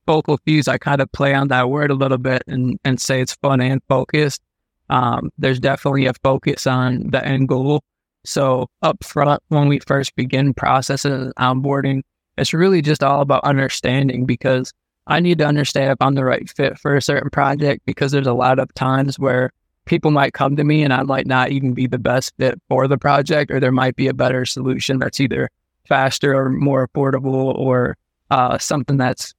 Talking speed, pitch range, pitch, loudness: 200 wpm, 130-140 Hz, 135 Hz, -17 LUFS